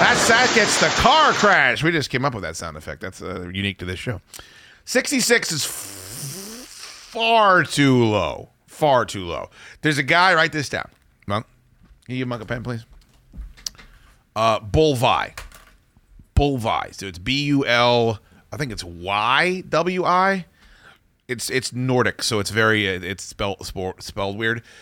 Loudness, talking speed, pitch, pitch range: -19 LUFS, 160 wpm, 120 Hz, 100-155 Hz